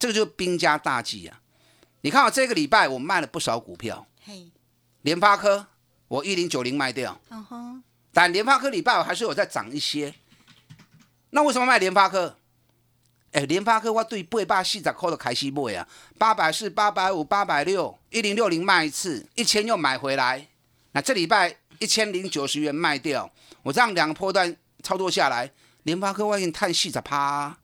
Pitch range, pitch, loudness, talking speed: 145-215 Hz, 180 Hz, -23 LUFS, 280 characters per minute